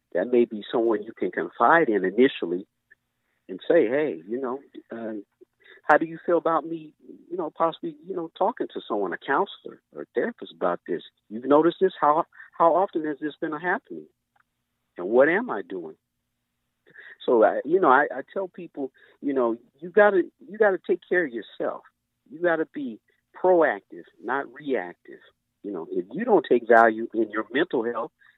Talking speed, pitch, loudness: 180 wpm, 170 Hz, -24 LUFS